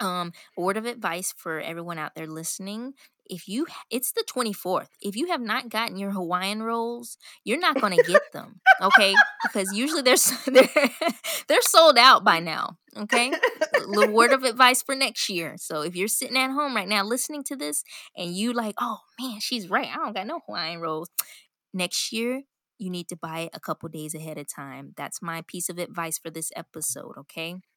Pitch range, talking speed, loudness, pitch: 175-260 Hz, 205 wpm, -23 LUFS, 210 Hz